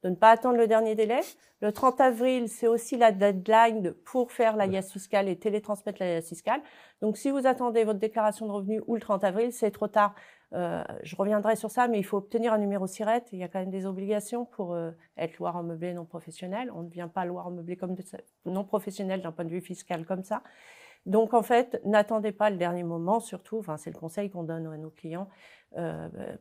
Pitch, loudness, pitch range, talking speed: 205 Hz, -28 LUFS, 180-225 Hz, 235 wpm